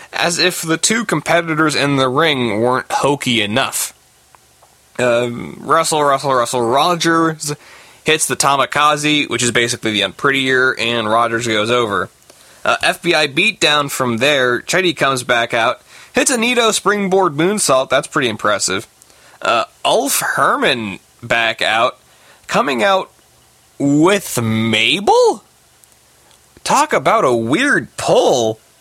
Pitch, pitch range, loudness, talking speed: 140 Hz, 120-165 Hz, -15 LUFS, 125 wpm